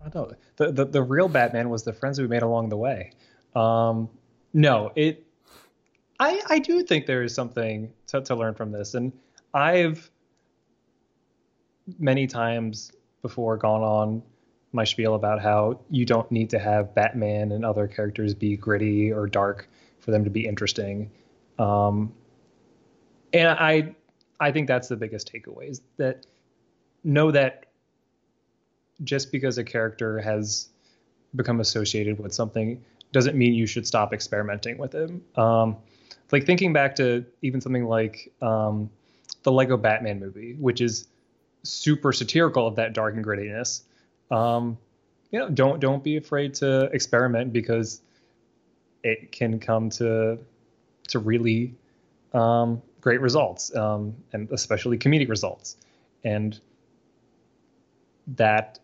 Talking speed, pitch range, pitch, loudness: 140 wpm, 110-135 Hz, 115 Hz, -24 LUFS